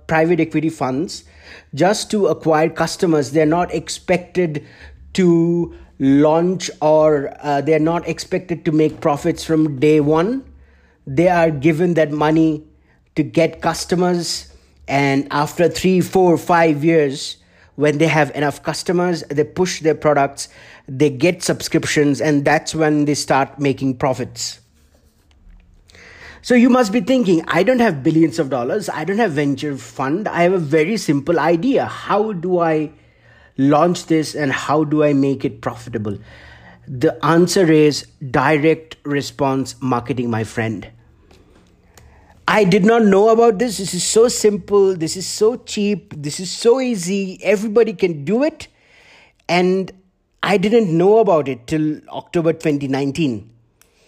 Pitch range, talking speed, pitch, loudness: 140-180 Hz, 145 wpm, 155 Hz, -17 LUFS